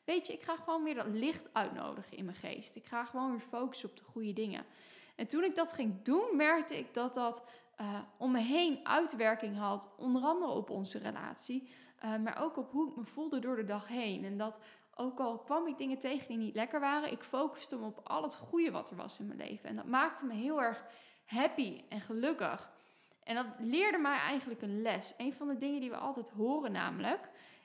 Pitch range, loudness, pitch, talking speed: 225-295 Hz, -37 LUFS, 255 Hz, 225 wpm